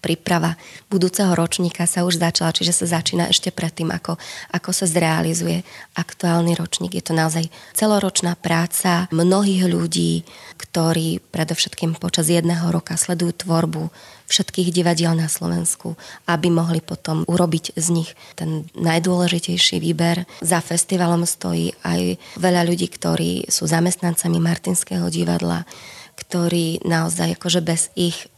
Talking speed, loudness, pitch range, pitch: 130 wpm, -20 LUFS, 160-175 Hz, 170 Hz